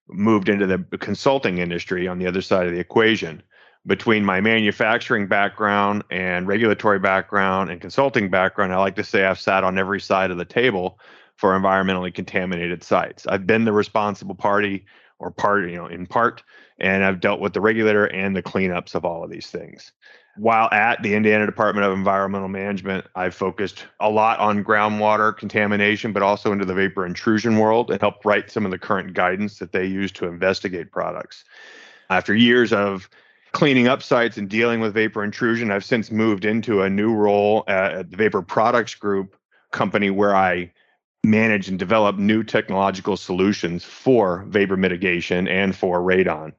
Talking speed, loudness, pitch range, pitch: 175 wpm, -20 LUFS, 95-105 Hz, 100 Hz